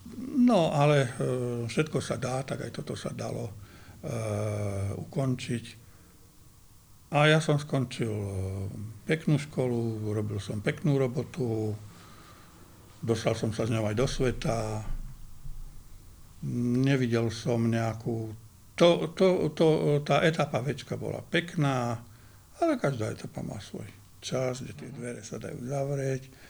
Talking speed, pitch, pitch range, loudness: 120 wpm, 120 Hz, 105-140 Hz, -29 LUFS